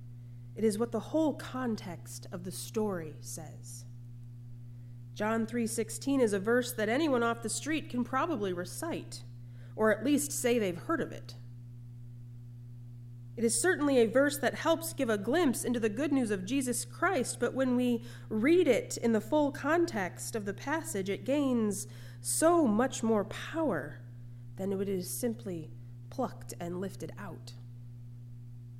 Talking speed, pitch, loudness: 155 wpm, 195 Hz, -31 LUFS